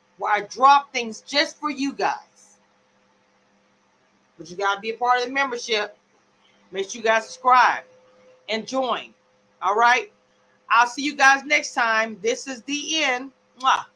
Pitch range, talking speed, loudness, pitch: 205-275 Hz, 160 wpm, -21 LUFS, 240 Hz